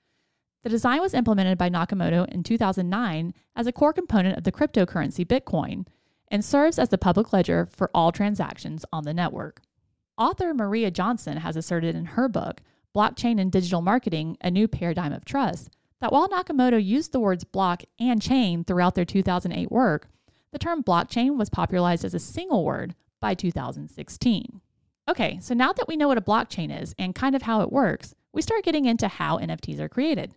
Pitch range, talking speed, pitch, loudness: 175-245 Hz, 185 wpm, 205 Hz, -25 LUFS